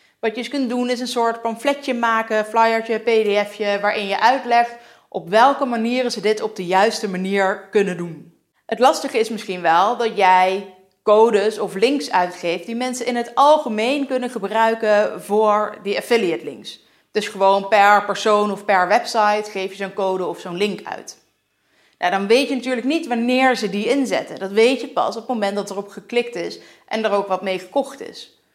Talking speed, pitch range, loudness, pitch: 190 wpm, 200-240 Hz, -19 LUFS, 215 Hz